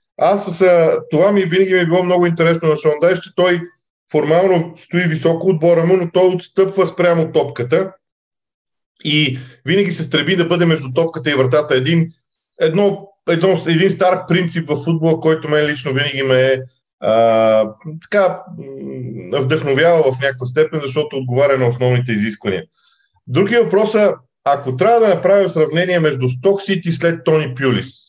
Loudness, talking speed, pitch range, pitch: -15 LUFS, 155 wpm, 140-180 Hz, 165 Hz